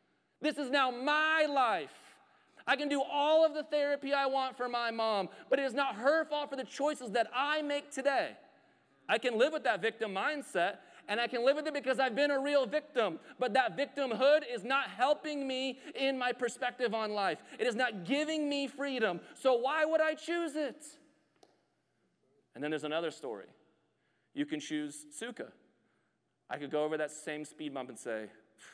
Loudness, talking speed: -33 LUFS, 190 wpm